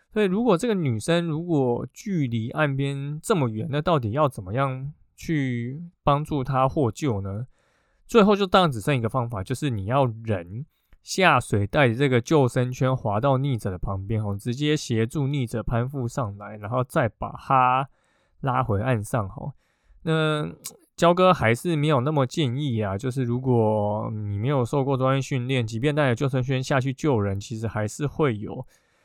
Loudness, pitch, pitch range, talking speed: -24 LUFS, 130 Hz, 115-150 Hz, 260 characters per minute